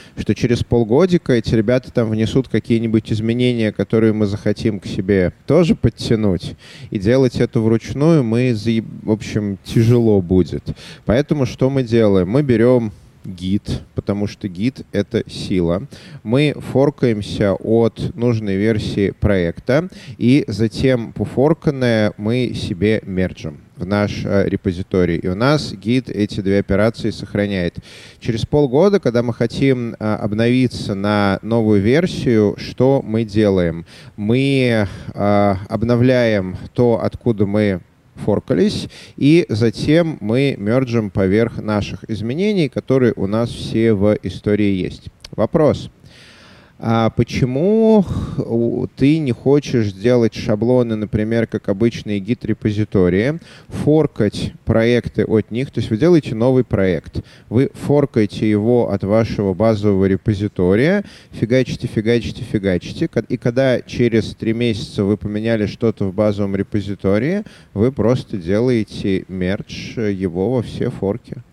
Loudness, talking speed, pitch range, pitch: -17 LUFS, 120 wpm, 105-125 Hz, 115 Hz